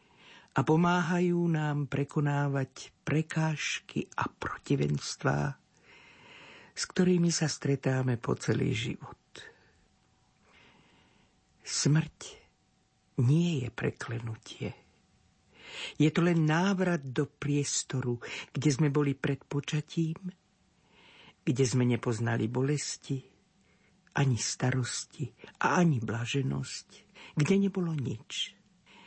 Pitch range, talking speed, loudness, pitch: 130-170 Hz, 85 wpm, -31 LUFS, 150 Hz